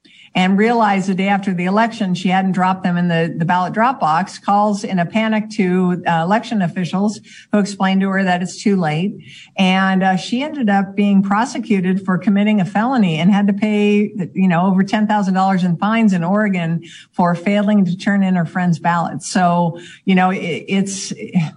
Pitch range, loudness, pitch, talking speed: 180-210 Hz, -16 LUFS, 195 Hz, 190 wpm